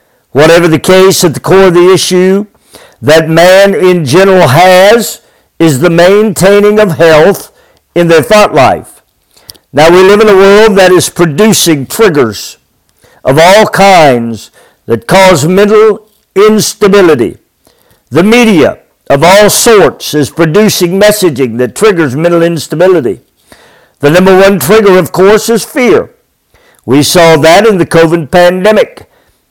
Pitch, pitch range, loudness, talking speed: 180 Hz, 165-205 Hz, -5 LUFS, 135 wpm